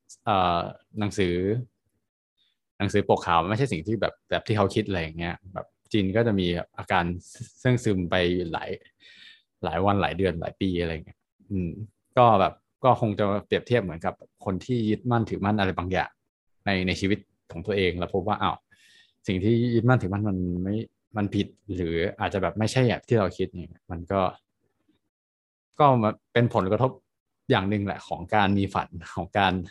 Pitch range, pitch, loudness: 90-110 Hz, 100 Hz, -26 LUFS